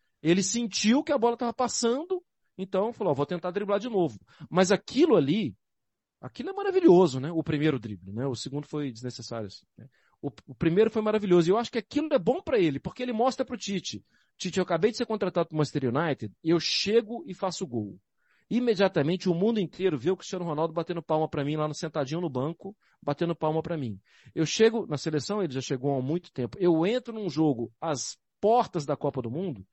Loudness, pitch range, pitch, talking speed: -28 LUFS, 145-215 Hz, 175 Hz, 215 wpm